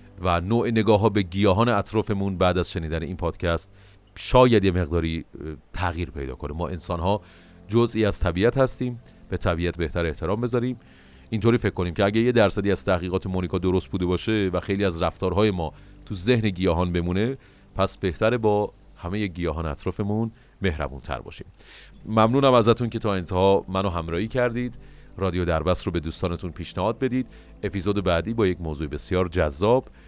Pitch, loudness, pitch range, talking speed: 95 Hz, -24 LUFS, 85-110 Hz, 165 wpm